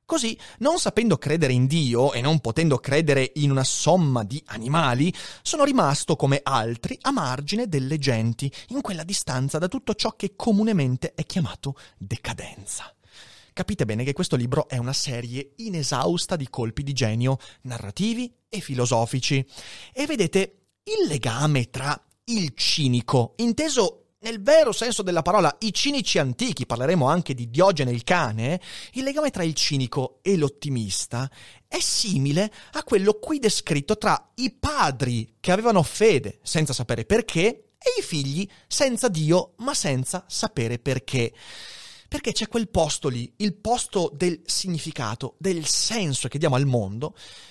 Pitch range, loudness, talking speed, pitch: 130-210 Hz, -24 LUFS, 150 wpm, 155 Hz